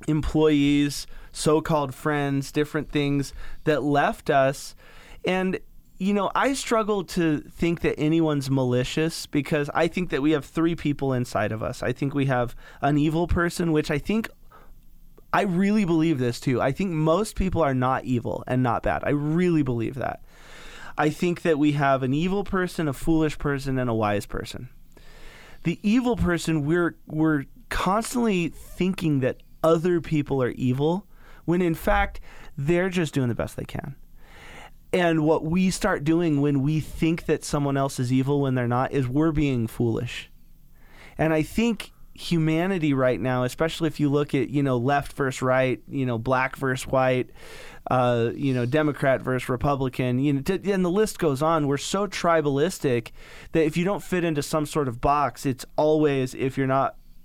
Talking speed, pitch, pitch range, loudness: 175 wpm, 150 Hz, 130-165 Hz, -24 LUFS